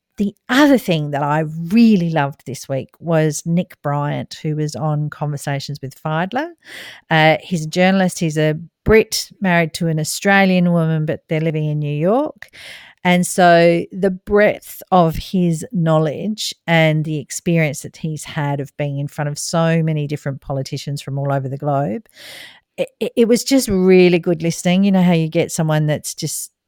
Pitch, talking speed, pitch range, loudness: 165 Hz, 175 wpm, 150-185 Hz, -17 LUFS